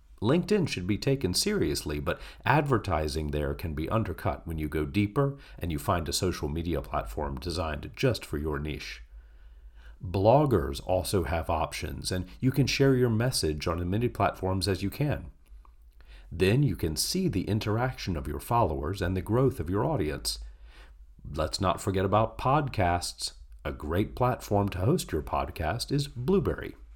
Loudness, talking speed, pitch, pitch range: -29 LUFS, 165 wpm, 90 Hz, 75-115 Hz